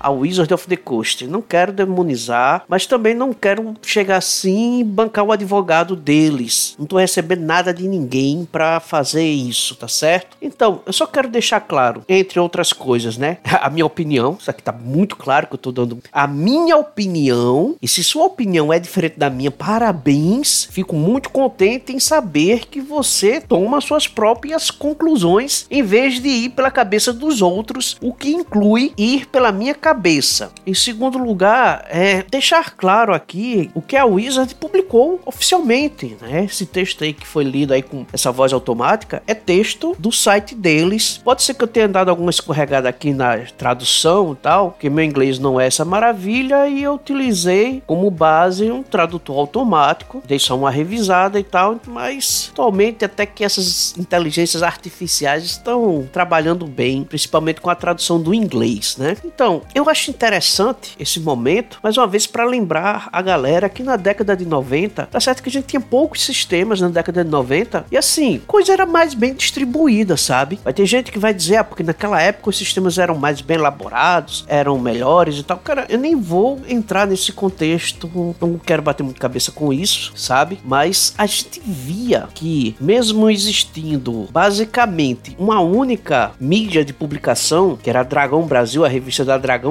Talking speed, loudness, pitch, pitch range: 180 wpm, -16 LUFS, 185 Hz, 150-235 Hz